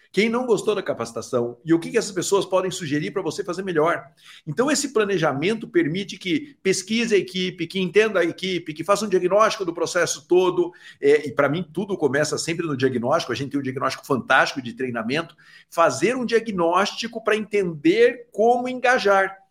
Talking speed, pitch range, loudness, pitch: 185 wpm, 170-230 Hz, -22 LUFS, 195 Hz